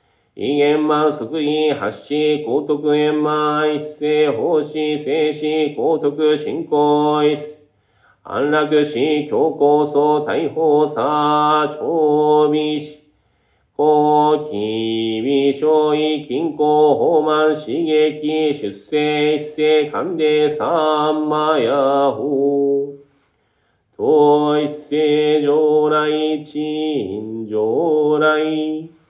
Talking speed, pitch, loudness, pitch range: 130 characters per minute, 150 Hz, -17 LUFS, 145-150 Hz